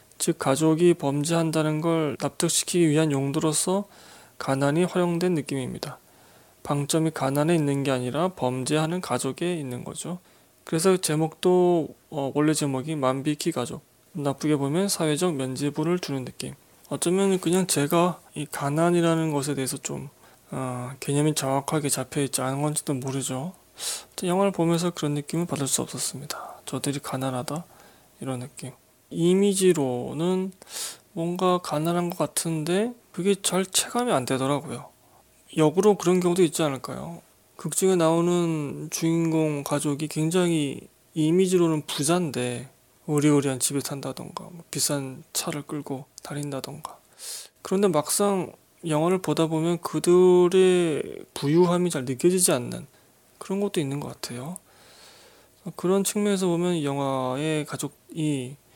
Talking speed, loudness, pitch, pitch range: 300 characters per minute, -25 LUFS, 155 Hz, 140-175 Hz